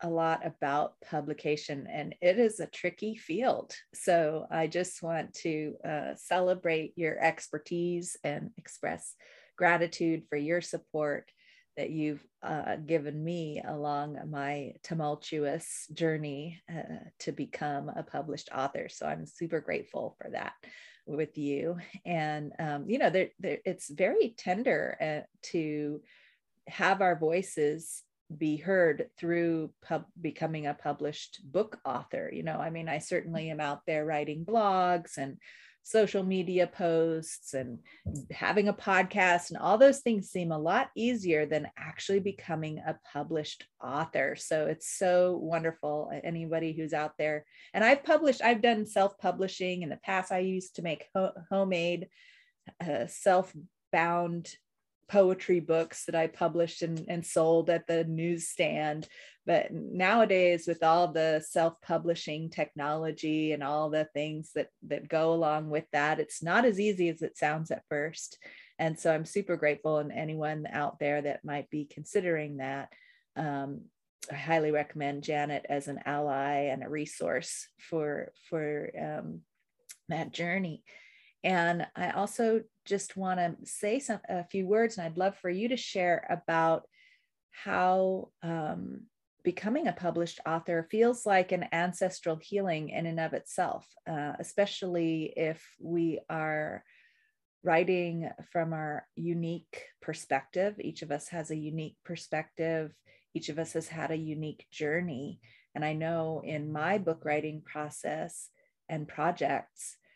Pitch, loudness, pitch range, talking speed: 165 Hz, -32 LUFS, 150-185 Hz, 145 wpm